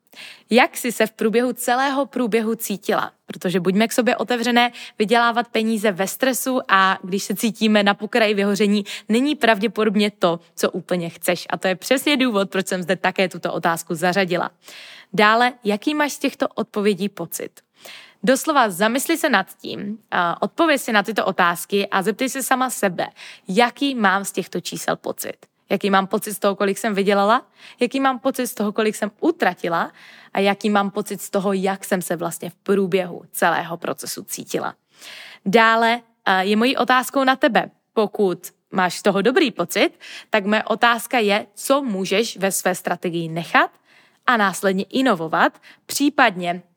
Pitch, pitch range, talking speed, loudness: 215 Hz, 195-245 Hz, 165 wpm, -20 LUFS